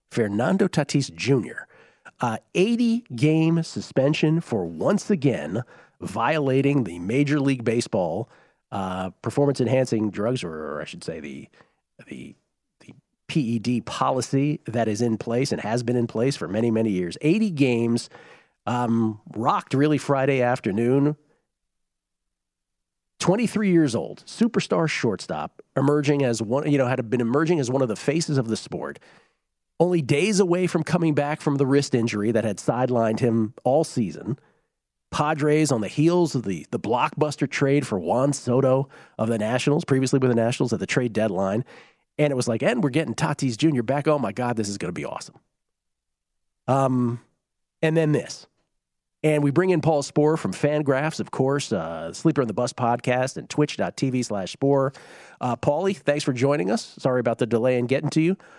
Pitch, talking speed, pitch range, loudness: 135 Hz, 170 wpm, 115-150 Hz, -23 LUFS